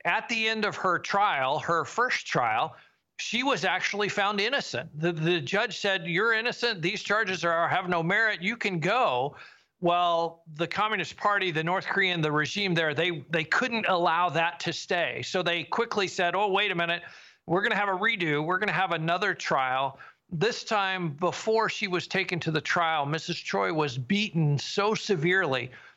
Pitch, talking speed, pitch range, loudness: 180 Hz, 185 wpm, 165-205 Hz, -27 LUFS